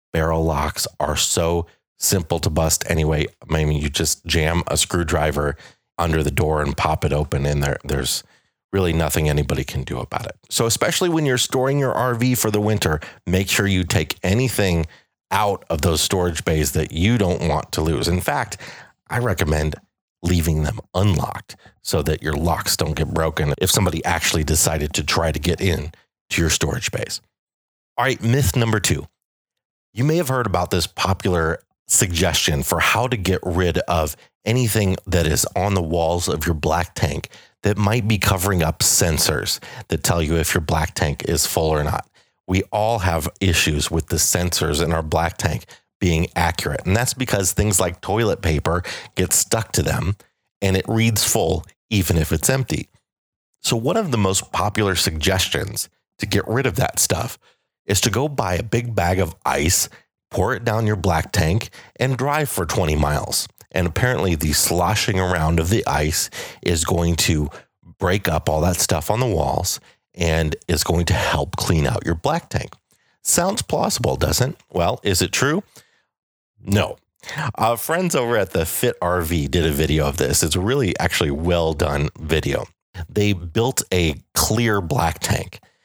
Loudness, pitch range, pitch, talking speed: -20 LUFS, 80-105 Hz, 90 Hz, 180 wpm